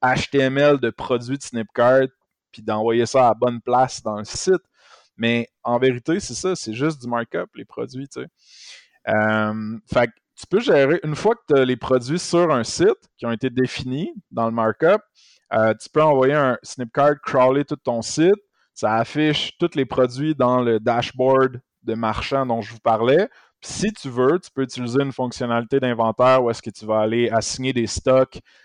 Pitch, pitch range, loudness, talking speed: 125 Hz, 115-140 Hz, -20 LUFS, 195 wpm